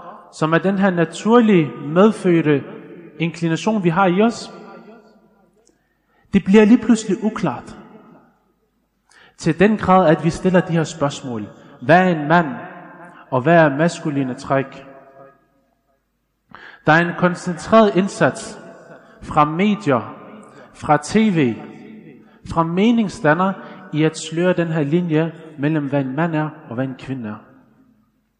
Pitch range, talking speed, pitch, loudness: 150-195 Hz, 130 wpm, 170 Hz, -17 LUFS